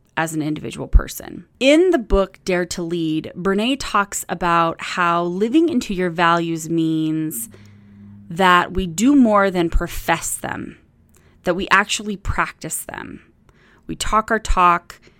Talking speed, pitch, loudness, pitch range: 140 wpm, 175 Hz, -19 LUFS, 160-200 Hz